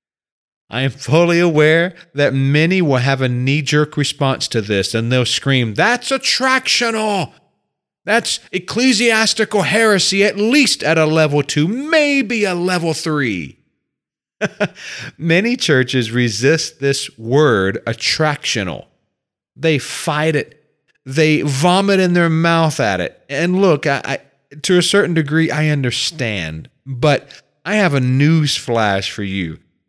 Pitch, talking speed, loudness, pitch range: 155 Hz, 130 wpm, -15 LUFS, 135-180 Hz